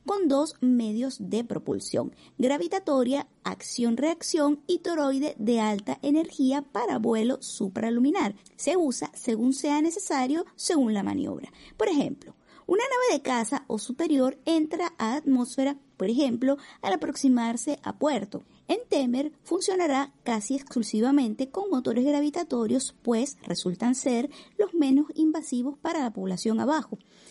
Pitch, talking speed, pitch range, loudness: 275 Hz, 125 wpm, 240-310 Hz, -27 LUFS